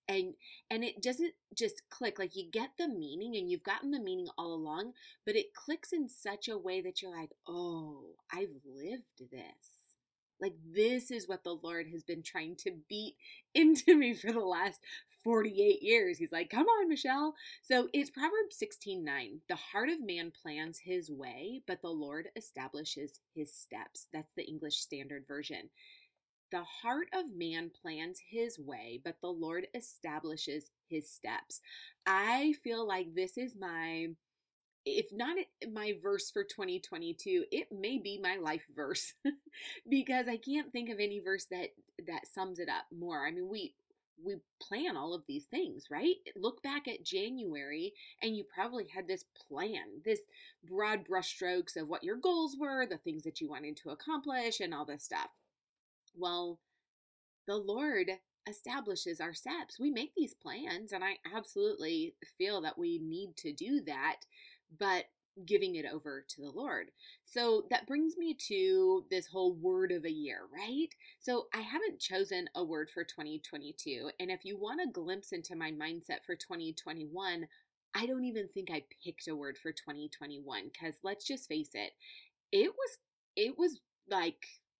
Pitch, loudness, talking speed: 230 Hz, -37 LUFS, 170 wpm